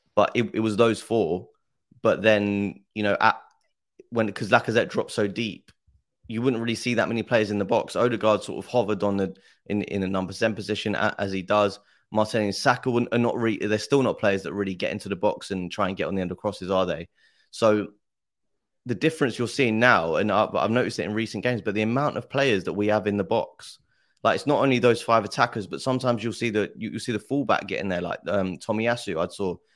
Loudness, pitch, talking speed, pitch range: -25 LUFS, 110 Hz, 235 wpm, 100-120 Hz